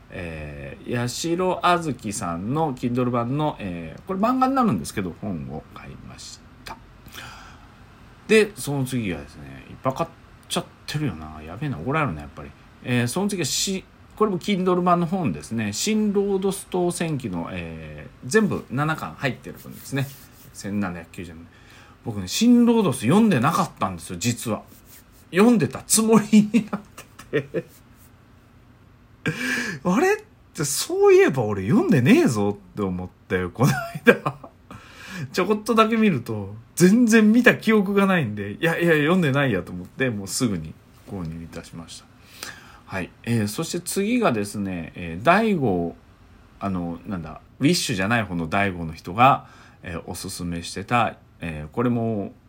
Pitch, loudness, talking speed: 120 Hz, -22 LUFS, 315 characters per minute